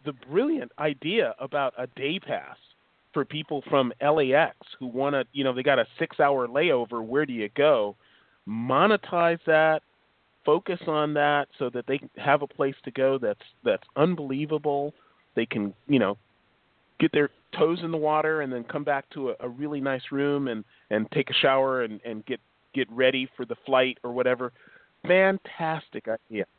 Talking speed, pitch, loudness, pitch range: 180 wpm, 140 Hz, -26 LUFS, 125-150 Hz